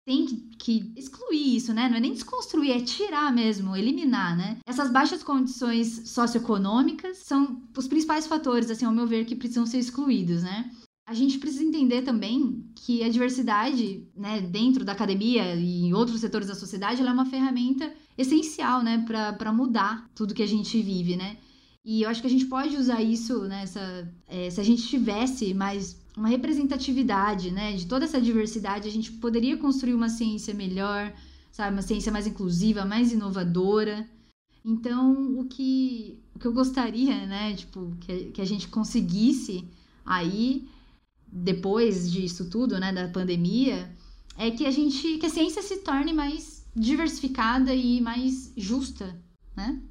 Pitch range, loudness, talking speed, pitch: 205-260 Hz, -26 LUFS, 165 wpm, 235 Hz